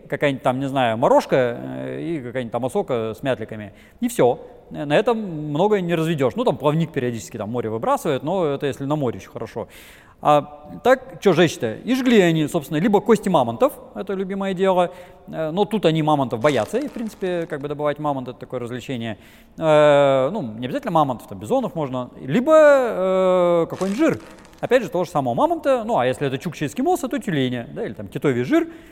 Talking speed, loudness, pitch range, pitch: 190 wpm, -20 LUFS, 135-205 Hz, 160 Hz